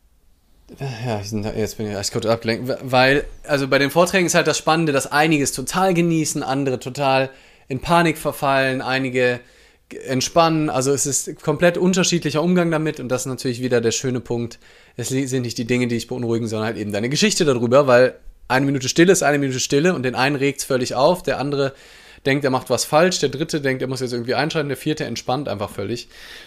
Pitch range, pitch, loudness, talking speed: 125-150 Hz, 135 Hz, -19 LUFS, 210 wpm